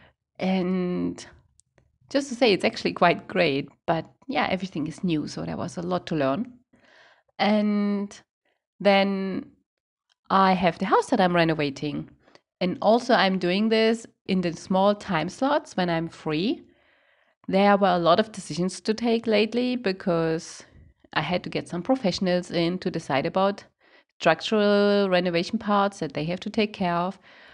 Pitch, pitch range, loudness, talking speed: 190 Hz, 170-220 Hz, -24 LUFS, 155 wpm